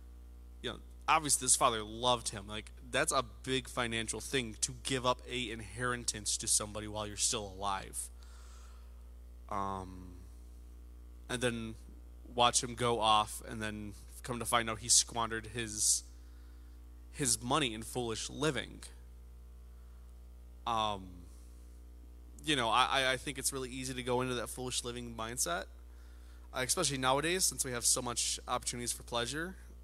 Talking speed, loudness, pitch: 145 wpm, -33 LUFS, 105 Hz